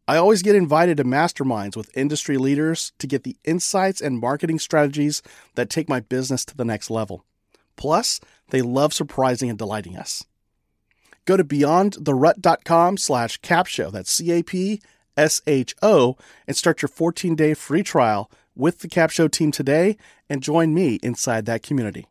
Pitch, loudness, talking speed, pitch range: 150 Hz, -21 LUFS, 150 wpm, 125-165 Hz